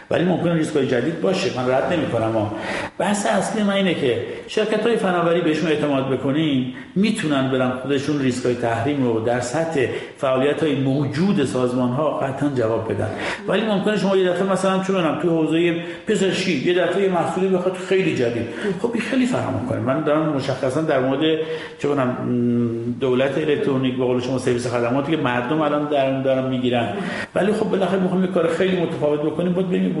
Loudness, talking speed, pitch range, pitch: -20 LUFS, 180 wpm, 130-180 Hz, 150 Hz